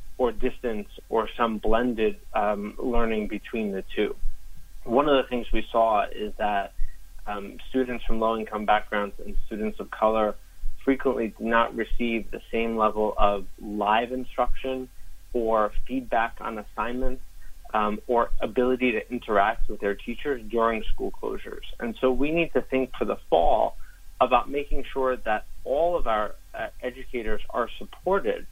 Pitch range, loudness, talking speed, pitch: 105-125 Hz, -27 LUFS, 155 wpm, 115 Hz